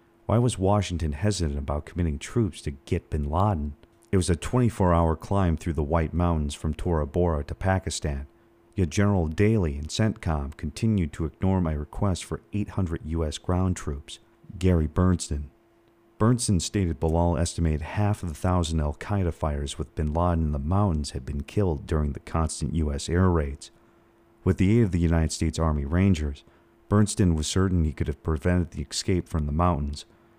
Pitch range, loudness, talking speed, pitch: 80-100 Hz, -26 LUFS, 180 wpm, 85 Hz